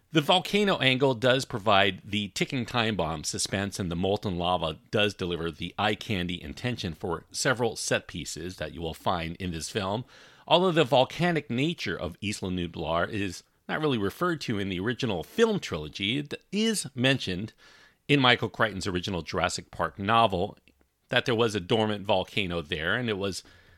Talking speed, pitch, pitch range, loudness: 170 wpm, 105 Hz, 90-125 Hz, -27 LUFS